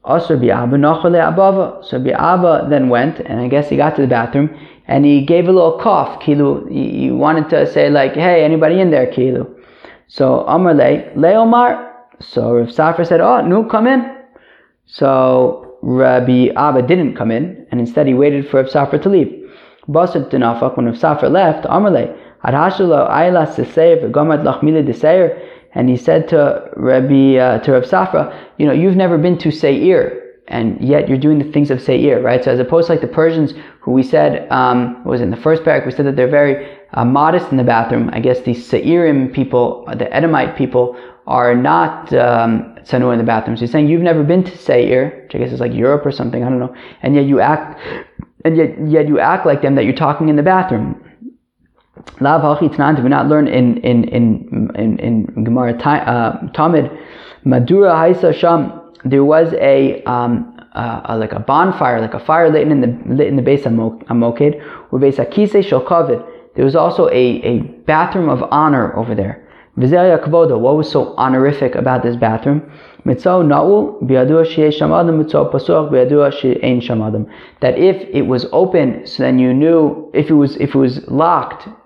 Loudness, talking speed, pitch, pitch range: -13 LUFS, 170 wpm, 145 Hz, 125-165 Hz